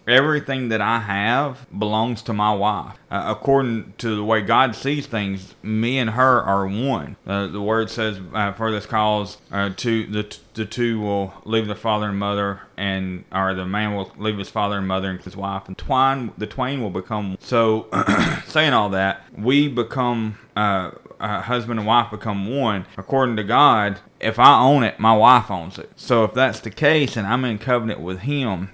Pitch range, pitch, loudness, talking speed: 100-120 Hz, 110 Hz, -20 LUFS, 200 wpm